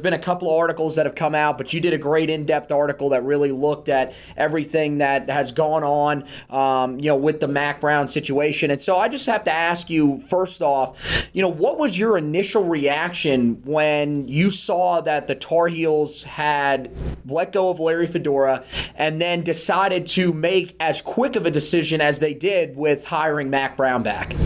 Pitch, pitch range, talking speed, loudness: 150 Hz, 145-170 Hz, 200 wpm, -21 LUFS